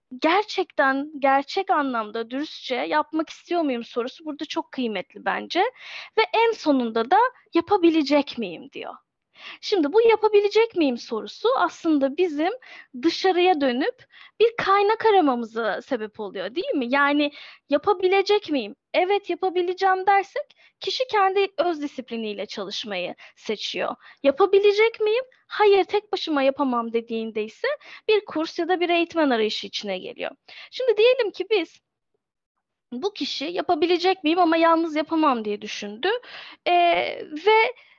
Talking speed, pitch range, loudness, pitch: 125 wpm, 260-395 Hz, -23 LUFS, 325 Hz